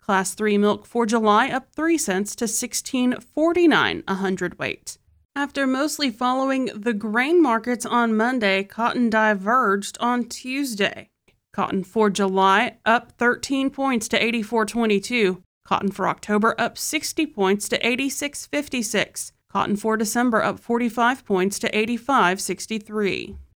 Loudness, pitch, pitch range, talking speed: -22 LUFS, 230 Hz, 205-255 Hz, 155 wpm